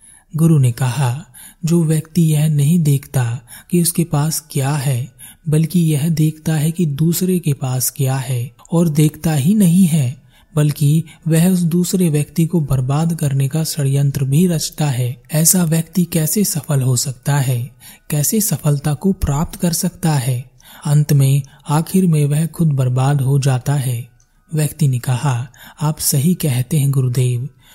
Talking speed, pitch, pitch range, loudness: 160 wpm, 150 Hz, 135-165 Hz, -16 LUFS